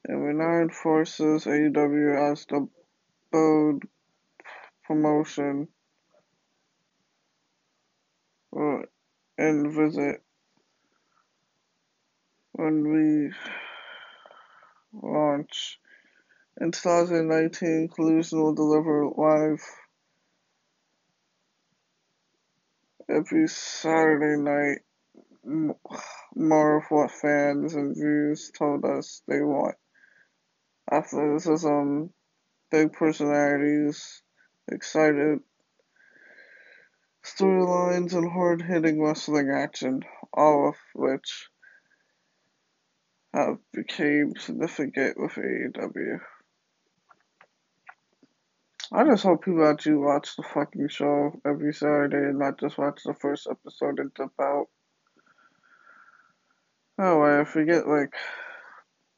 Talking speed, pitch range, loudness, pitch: 85 wpm, 145-175 Hz, -25 LUFS, 155 Hz